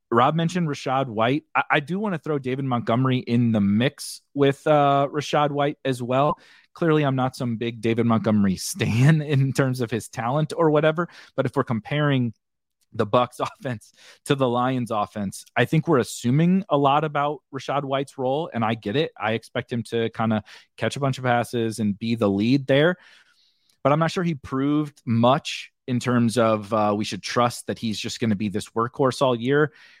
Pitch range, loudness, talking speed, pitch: 115-145 Hz, -23 LUFS, 200 wpm, 130 Hz